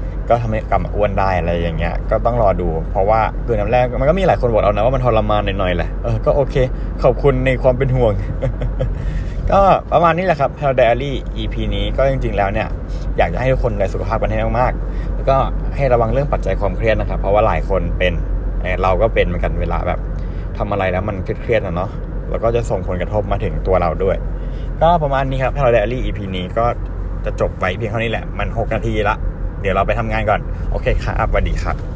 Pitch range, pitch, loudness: 90-115 Hz, 105 Hz, -18 LUFS